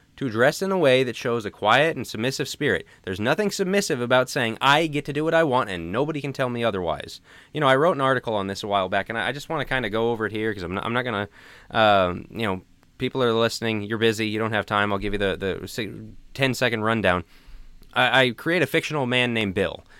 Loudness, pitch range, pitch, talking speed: -23 LUFS, 105-135 Hz, 120 Hz, 260 wpm